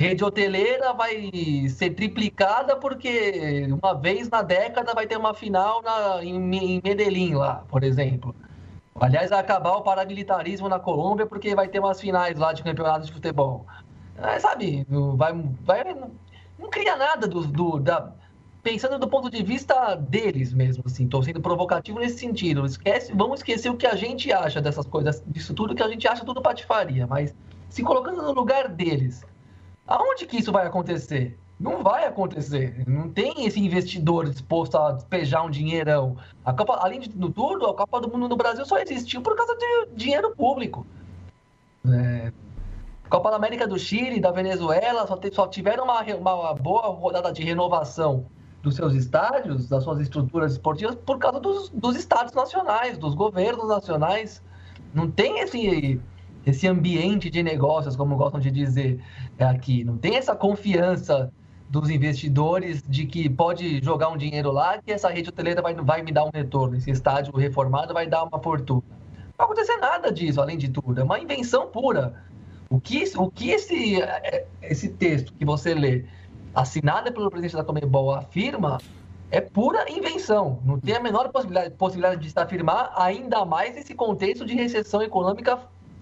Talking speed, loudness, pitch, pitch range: 170 wpm, -24 LUFS, 175 Hz, 140-210 Hz